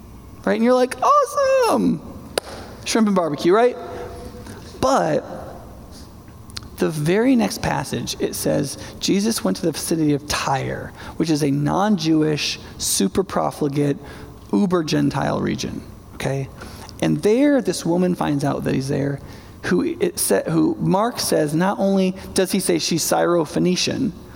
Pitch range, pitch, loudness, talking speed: 140-195 Hz, 160 Hz, -20 LUFS, 130 wpm